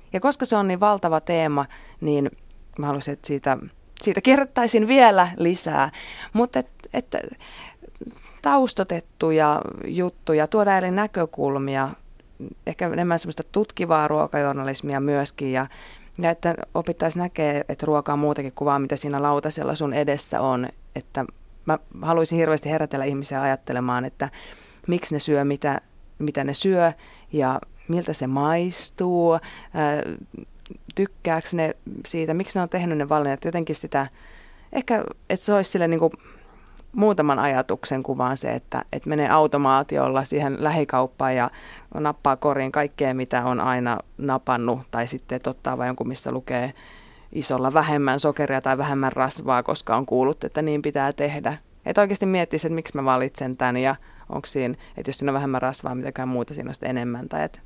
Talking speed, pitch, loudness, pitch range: 150 wpm, 150 Hz, -23 LUFS, 135-170 Hz